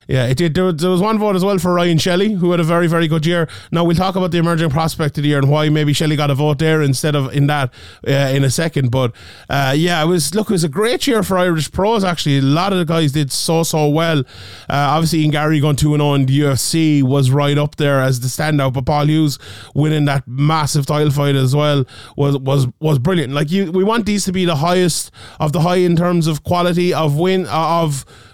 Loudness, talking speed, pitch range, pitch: -15 LUFS, 255 wpm, 140-175 Hz, 155 Hz